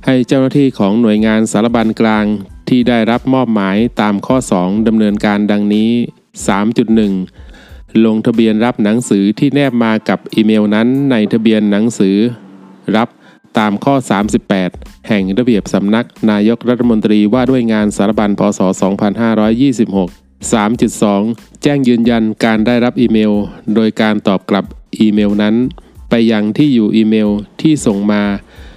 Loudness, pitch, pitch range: -12 LUFS, 110 Hz, 105-120 Hz